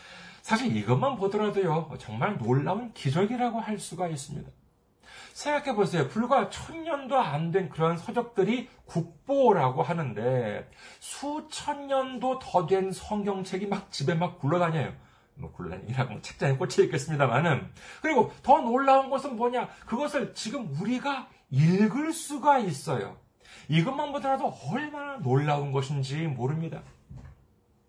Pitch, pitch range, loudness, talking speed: 195 Hz, 155-260 Hz, -28 LUFS, 295 characters per minute